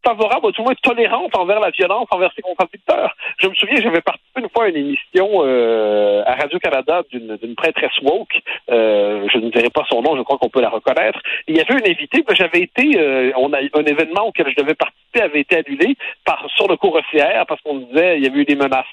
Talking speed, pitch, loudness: 245 wpm, 160 Hz, -16 LUFS